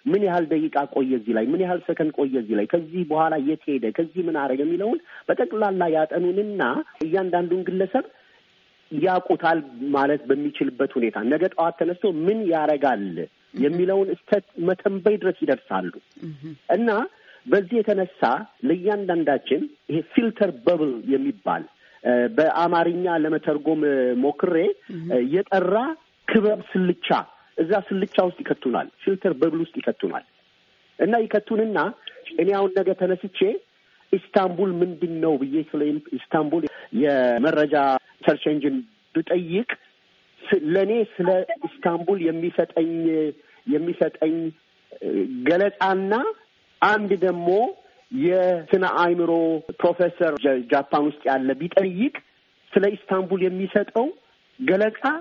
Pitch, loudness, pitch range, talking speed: 180 Hz, -23 LUFS, 155-205 Hz, 100 wpm